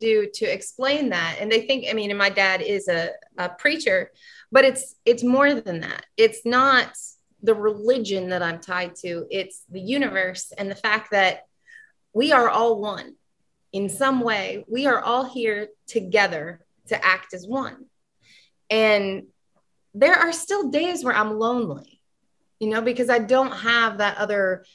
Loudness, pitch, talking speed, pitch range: -22 LUFS, 225 Hz, 165 wpm, 195-265 Hz